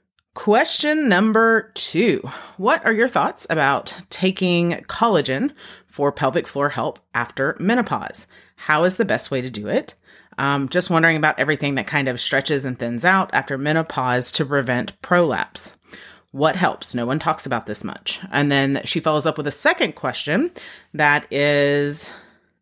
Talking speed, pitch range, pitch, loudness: 160 wpm, 140-175 Hz, 145 Hz, -20 LUFS